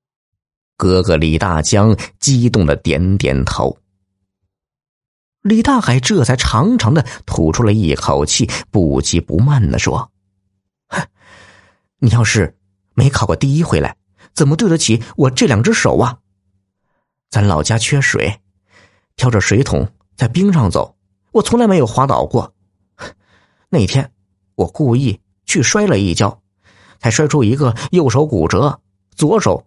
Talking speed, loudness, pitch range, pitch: 190 characters per minute, -14 LUFS, 95-130 Hz, 100 Hz